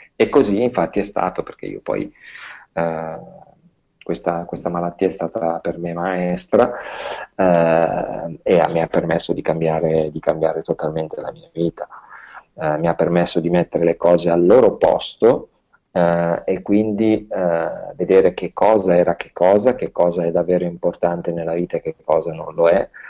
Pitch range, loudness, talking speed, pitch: 85-95 Hz, -18 LUFS, 165 wpm, 85 Hz